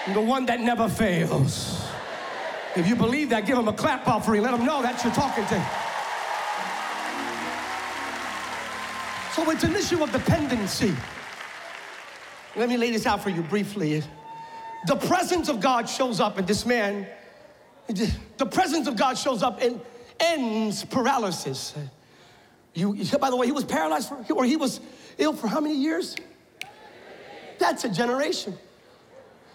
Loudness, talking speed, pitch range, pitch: -25 LUFS, 150 wpm, 205-280 Hz, 240 Hz